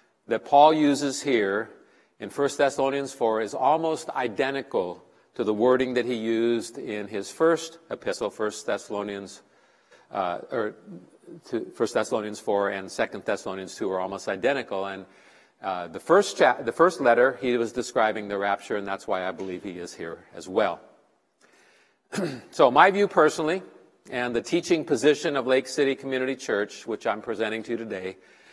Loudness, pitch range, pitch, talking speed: -25 LUFS, 100-140 Hz, 120 Hz, 165 wpm